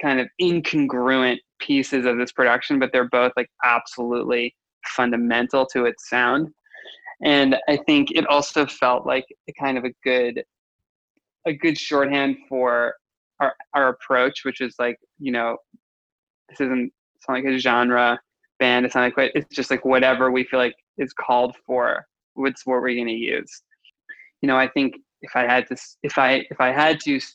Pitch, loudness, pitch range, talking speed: 130 Hz, -21 LUFS, 125-140 Hz, 180 wpm